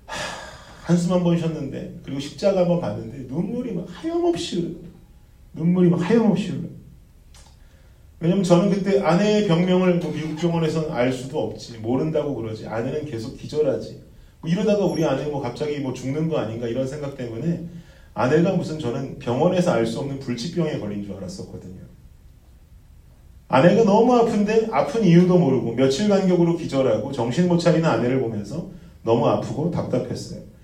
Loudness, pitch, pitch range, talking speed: -22 LUFS, 155 Hz, 125-180 Hz, 360 characters per minute